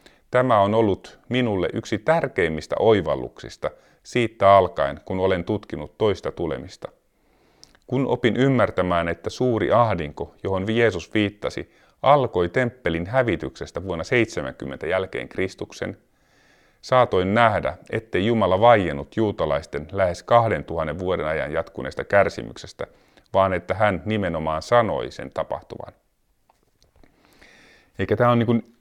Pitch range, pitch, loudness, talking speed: 90-120 Hz, 100 Hz, -22 LUFS, 110 wpm